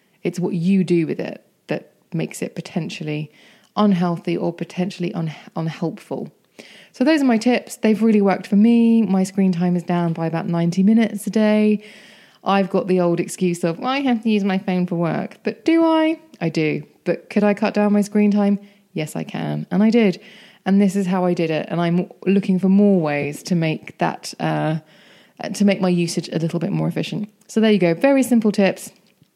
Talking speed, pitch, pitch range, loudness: 210 wpm, 190 Hz, 170-210 Hz, -19 LUFS